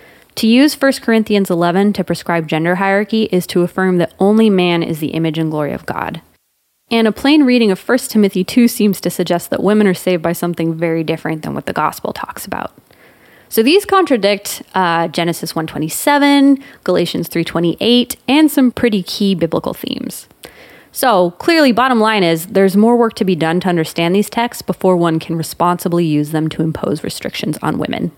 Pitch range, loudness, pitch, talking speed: 170-230 Hz, -14 LUFS, 185 Hz, 185 wpm